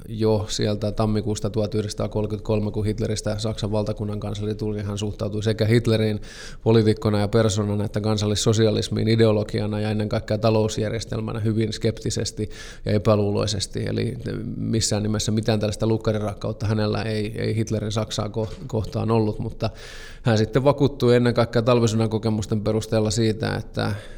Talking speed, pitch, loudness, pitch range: 130 wpm, 110 Hz, -23 LUFS, 105-115 Hz